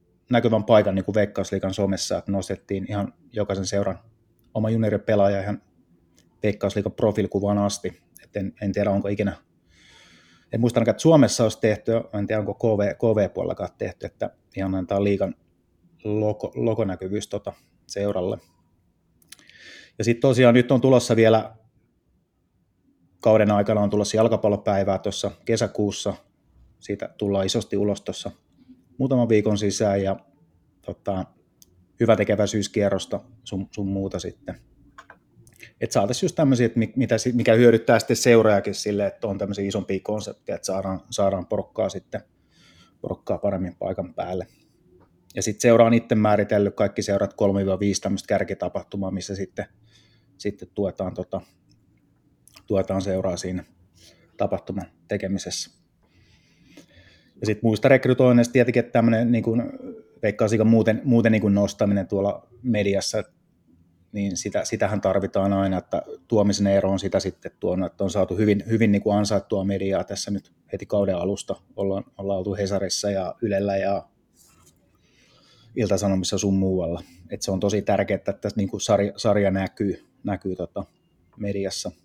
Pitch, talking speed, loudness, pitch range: 100 Hz, 135 wpm, -23 LUFS, 95-110 Hz